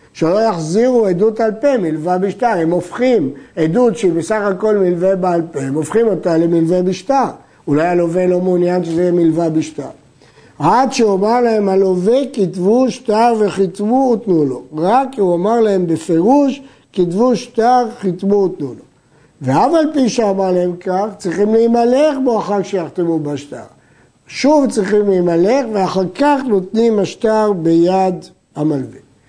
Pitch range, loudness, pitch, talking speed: 175-230 Hz, -14 LUFS, 195 Hz, 145 wpm